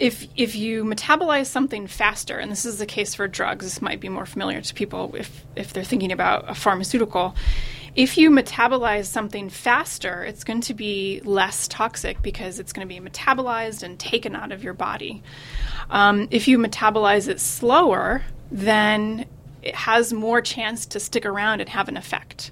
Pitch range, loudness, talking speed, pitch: 200-235 Hz, -22 LUFS, 180 wpm, 220 Hz